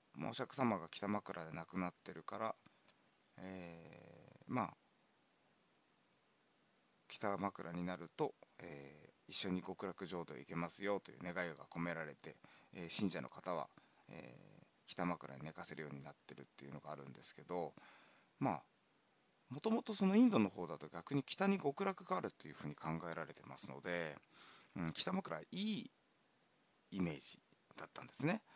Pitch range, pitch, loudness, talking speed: 80-105 Hz, 90 Hz, -43 LUFS, 305 characters per minute